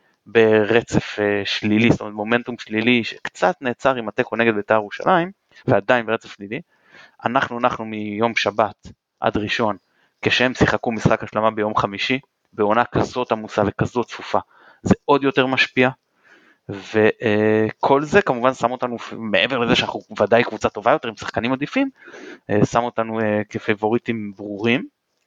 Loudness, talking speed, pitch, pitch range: -20 LUFS, 145 wpm, 115 Hz, 105-125 Hz